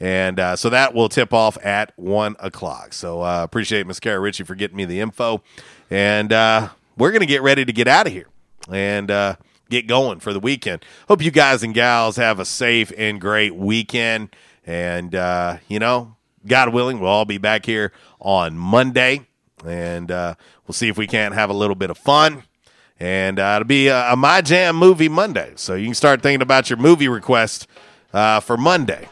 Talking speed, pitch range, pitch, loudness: 205 wpm, 95-125 Hz, 110 Hz, -17 LUFS